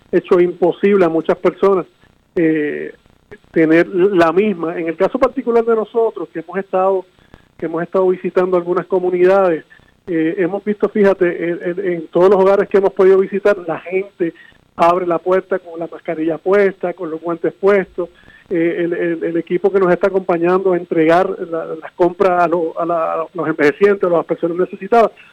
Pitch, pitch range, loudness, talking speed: 180 Hz, 170-195 Hz, -16 LUFS, 180 wpm